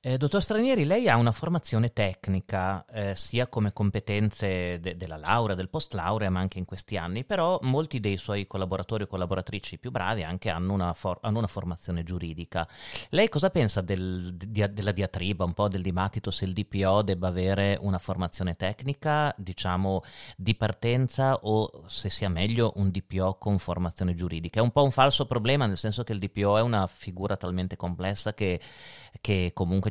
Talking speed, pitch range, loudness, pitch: 180 wpm, 95-115 Hz, -28 LUFS, 100 Hz